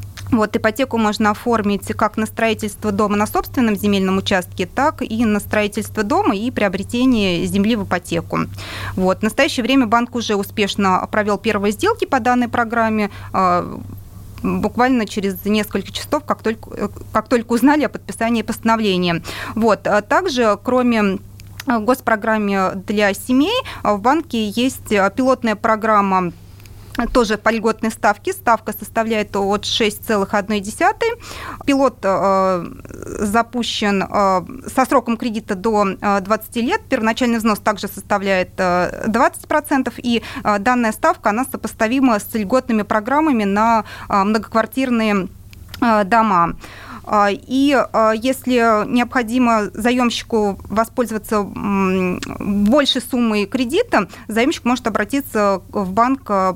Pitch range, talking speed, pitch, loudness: 205-245 Hz, 120 wpm, 220 Hz, -18 LUFS